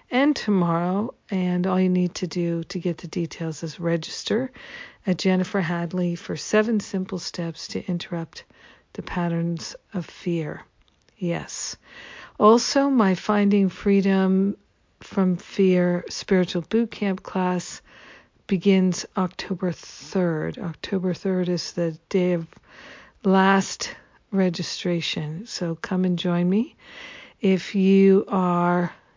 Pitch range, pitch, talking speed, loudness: 175-195 Hz, 185 Hz, 115 wpm, -23 LUFS